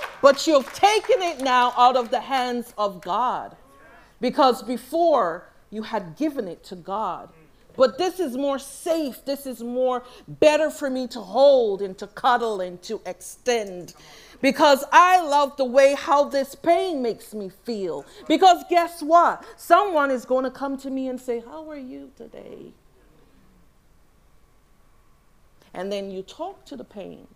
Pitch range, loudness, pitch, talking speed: 235-305 Hz, -21 LUFS, 265 Hz, 160 wpm